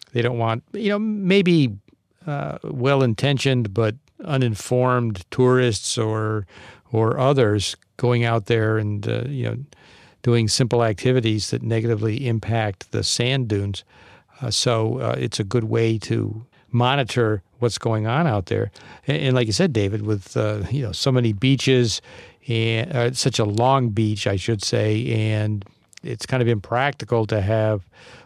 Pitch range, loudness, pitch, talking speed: 110-125 Hz, -21 LUFS, 115 Hz, 155 wpm